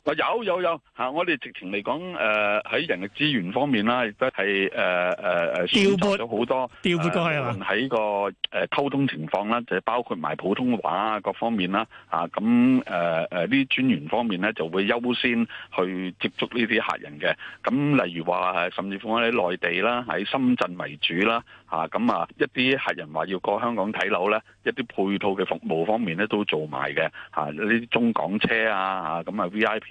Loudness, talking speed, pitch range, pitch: -24 LUFS, 260 characters per minute, 95-135 Hz, 110 Hz